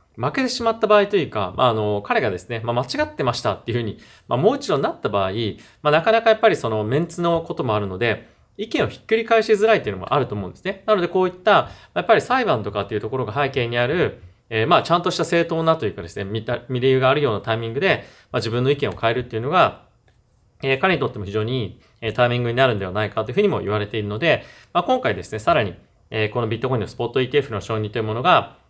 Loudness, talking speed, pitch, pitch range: -21 LUFS, 540 characters per minute, 125 Hz, 110-170 Hz